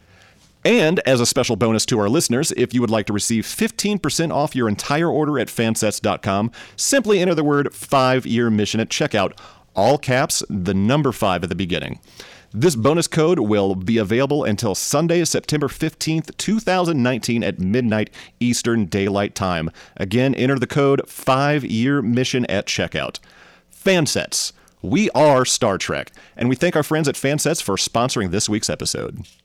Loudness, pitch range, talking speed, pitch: -19 LUFS, 105-145 Hz, 165 wpm, 125 Hz